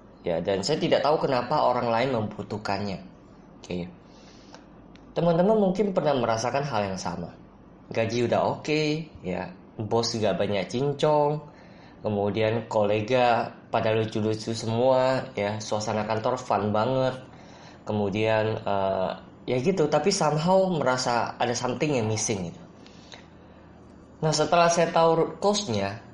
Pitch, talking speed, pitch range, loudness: 115 Hz, 125 wpm, 105-145 Hz, -25 LUFS